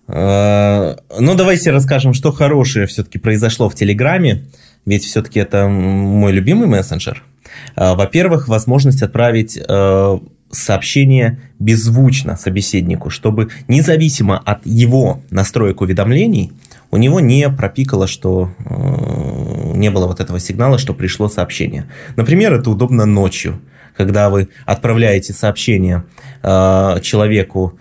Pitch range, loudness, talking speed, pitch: 100-130 Hz, -13 LUFS, 105 wpm, 110 Hz